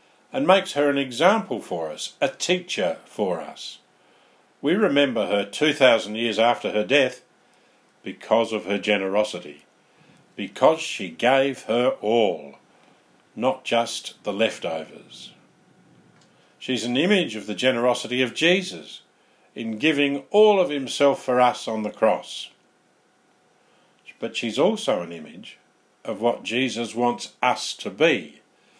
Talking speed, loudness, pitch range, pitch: 130 wpm, -22 LUFS, 110-145 Hz, 125 Hz